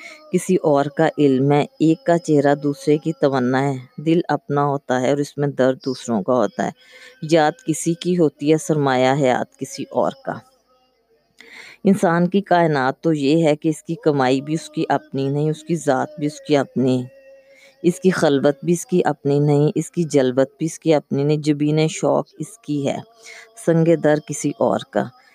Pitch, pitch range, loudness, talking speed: 155 Hz, 145-170 Hz, -19 LUFS, 200 wpm